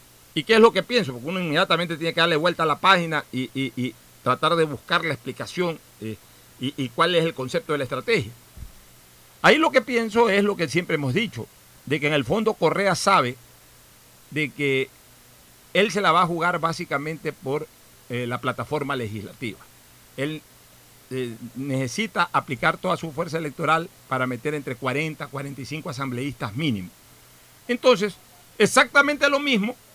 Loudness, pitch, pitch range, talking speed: -23 LUFS, 150 Hz, 130-175 Hz, 170 wpm